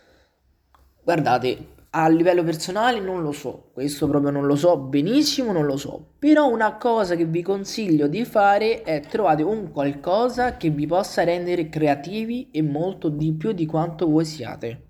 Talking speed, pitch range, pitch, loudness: 165 wpm, 150-210 Hz, 170 Hz, -22 LUFS